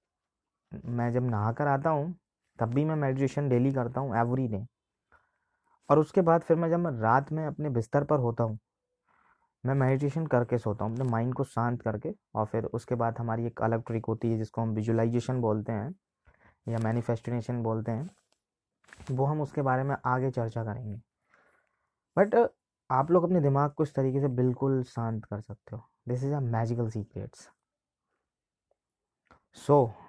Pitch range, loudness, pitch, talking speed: 115-145 Hz, -29 LUFS, 125 Hz, 170 wpm